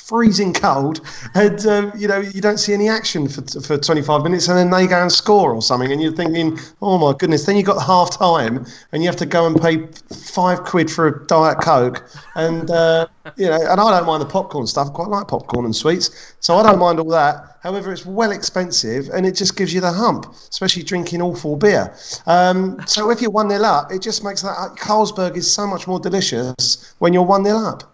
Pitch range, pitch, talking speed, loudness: 160-195 Hz, 175 Hz, 235 wpm, -16 LUFS